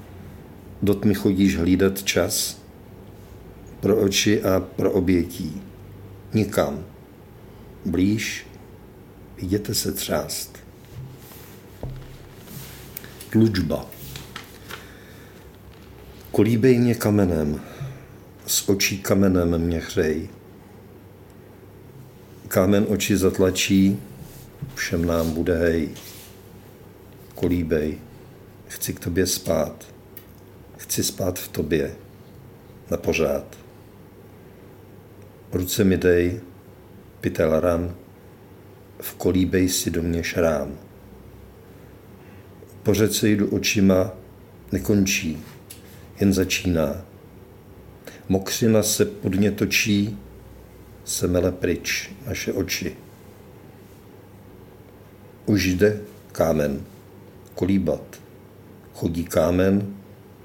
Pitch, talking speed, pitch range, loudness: 95 Hz, 75 wpm, 95-105 Hz, -22 LUFS